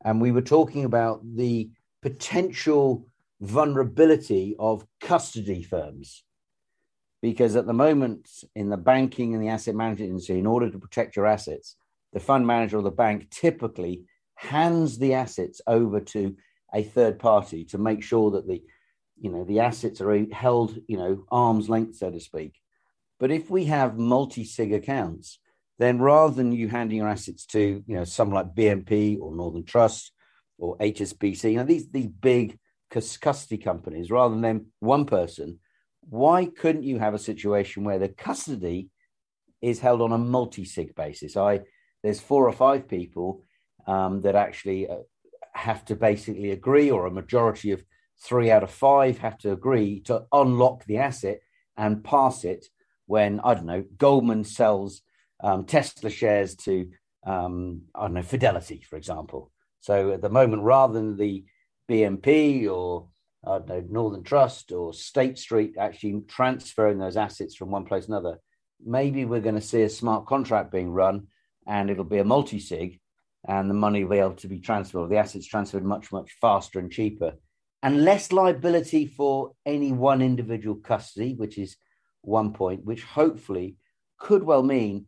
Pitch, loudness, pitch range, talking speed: 110 Hz, -24 LUFS, 100-130 Hz, 170 wpm